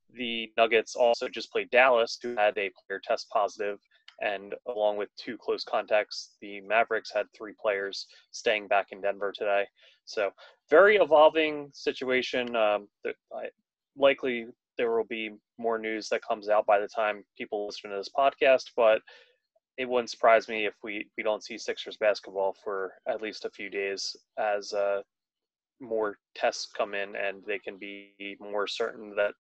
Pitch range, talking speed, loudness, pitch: 100-125 Hz, 165 wpm, -28 LUFS, 110 Hz